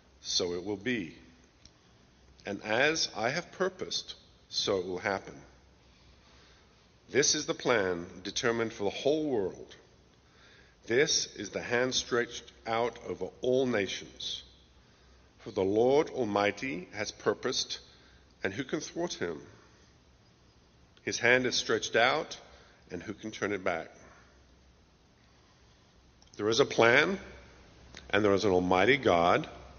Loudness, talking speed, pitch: -30 LUFS, 125 wpm, 85 Hz